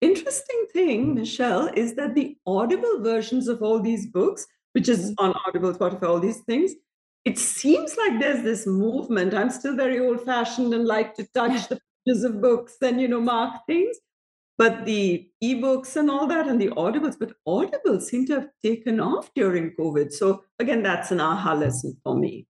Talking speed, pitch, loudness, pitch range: 190 wpm, 240 Hz, -24 LUFS, 210-275 Hz